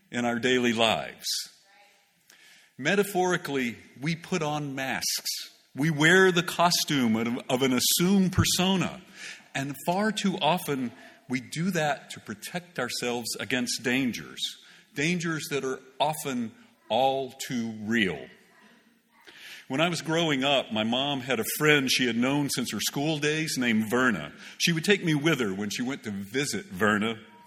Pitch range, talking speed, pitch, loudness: 125-175 Hz, 150 wpm, 145 Hz, -26 LUFS